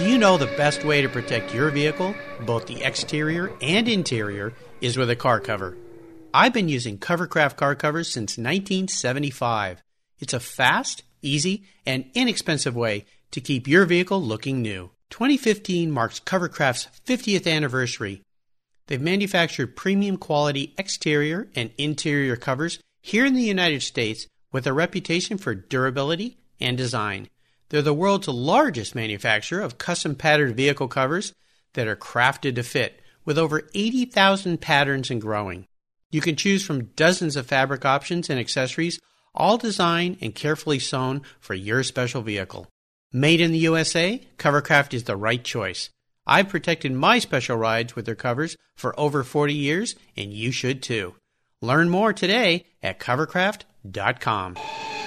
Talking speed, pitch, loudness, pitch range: 150 wpm, 145 Hz, -23 LUFS, 125-175 Hz